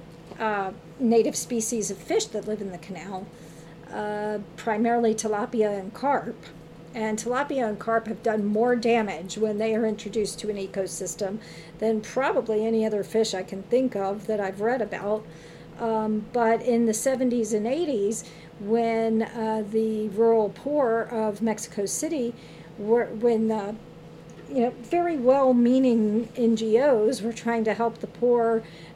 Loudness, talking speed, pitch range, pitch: -25 LUFS, 150 wpm, 200-230 Hz, 220 Hz